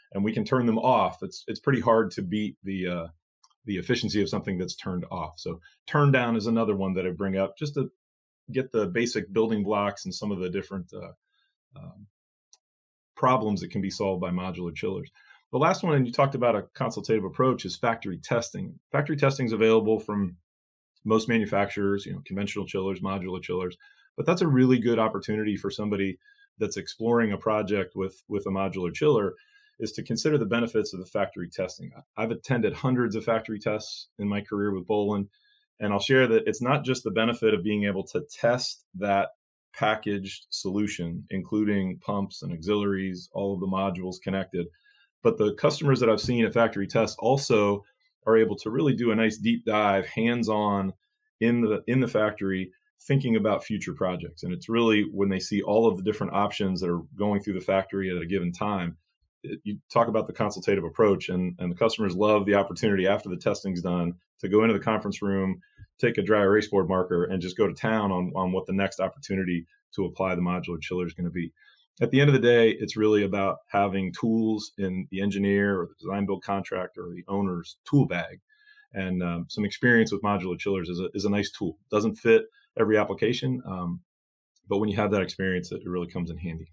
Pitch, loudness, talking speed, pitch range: 100 Hz, -26 LUFS, 205 wpm, 95-115 Hz